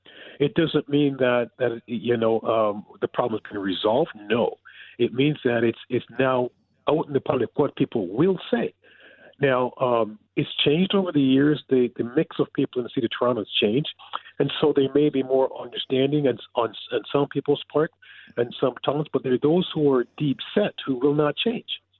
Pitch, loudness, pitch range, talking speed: 135 Hz, -24 LUFS, 120-145 Hz, 205 wpm